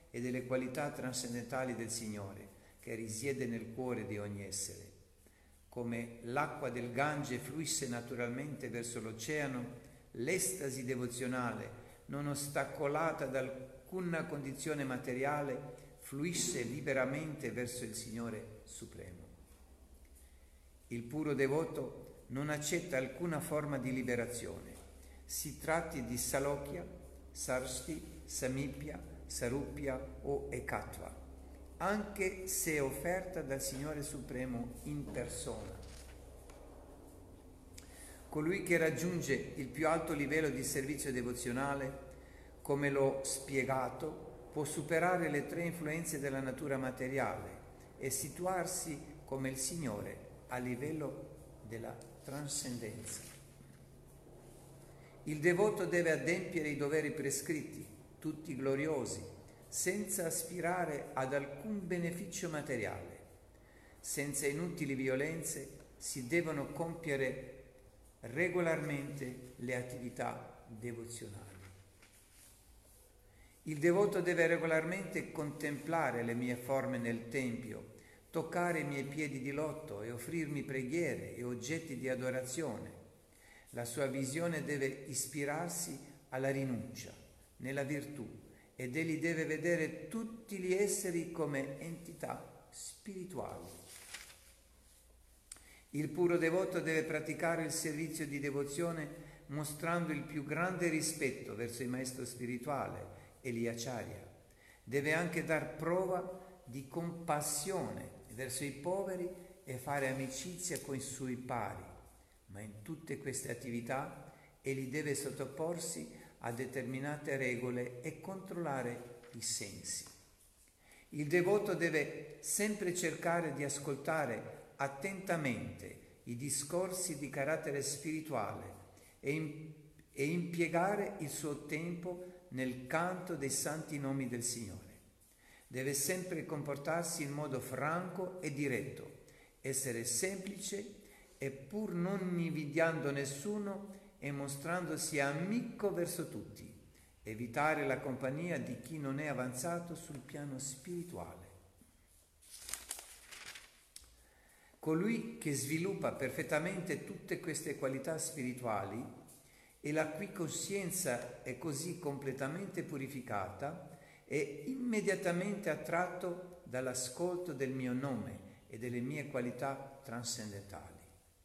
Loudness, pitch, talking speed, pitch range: -39 LUFS, 140 Hz, 100 wpm, 120-160 Hz